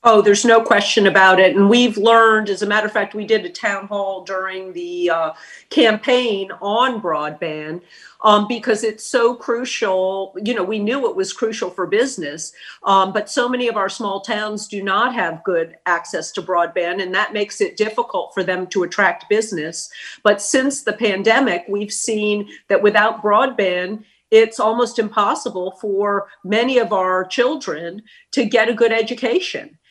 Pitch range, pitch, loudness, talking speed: 190-230 Hz, 210 Hz, -17 LUFS, 175 wpm